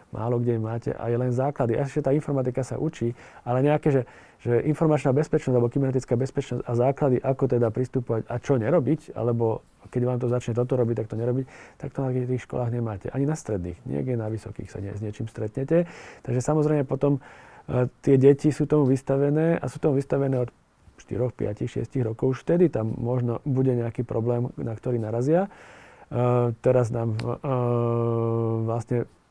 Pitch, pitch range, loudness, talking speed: 125 Hz, 120-140 Hz, -25 LUFS, 180 wpm